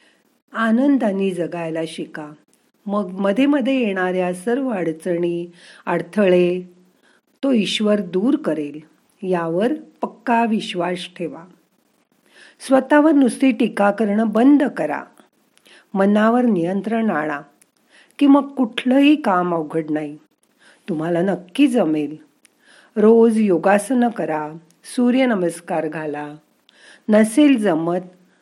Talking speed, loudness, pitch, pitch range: 90 wpm, -18 LUFS, 200 Hz, 175-245 Hz